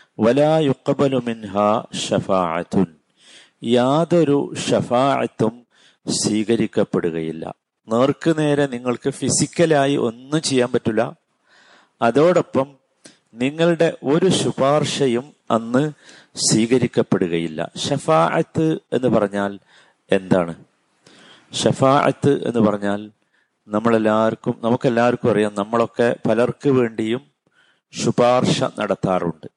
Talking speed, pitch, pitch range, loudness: 60 wpm, 120 Hz, 110-140 Hz, -19 LUFS